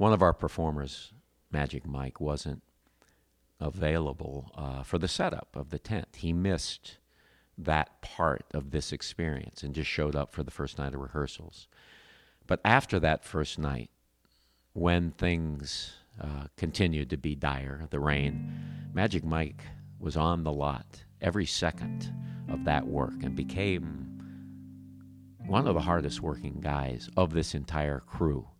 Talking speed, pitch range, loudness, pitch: 145 wpm, 70-85 Hz, -32 LUFS, 75 Hz